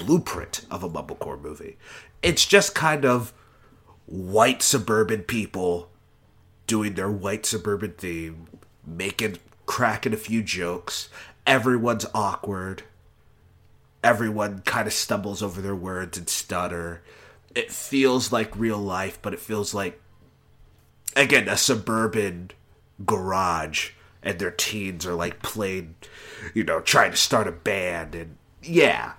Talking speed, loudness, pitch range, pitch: 125 wpm, -24 LUFS, 90-110 Hz, 100 Hz